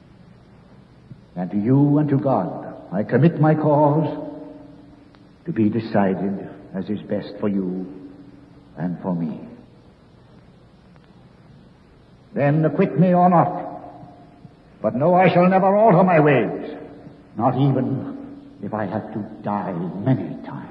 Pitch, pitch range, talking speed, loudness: 140 Hz, 105-155 Hz, 125 wpm, -20 LUFS